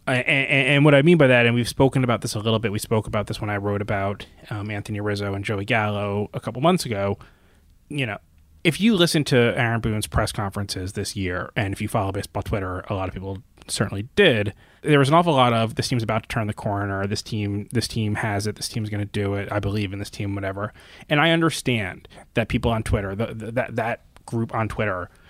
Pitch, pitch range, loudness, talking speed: 105 Hz, 100-120 Hz, -22 LUFS, 240 wpm